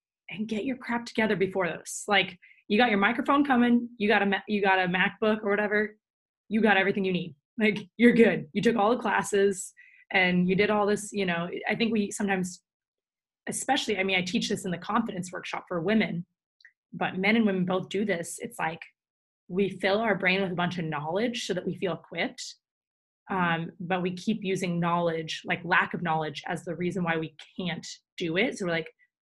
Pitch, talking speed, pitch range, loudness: 200 Hz, 210 wpm, 180-215 Hz, -27 LUFS